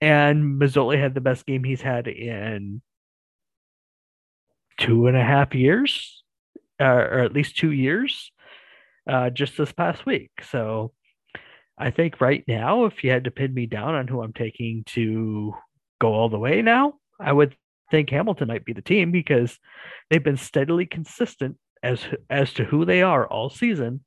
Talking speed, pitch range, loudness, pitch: 165 wpm, 120-160 Hz, -22 LUFS, 135 Hz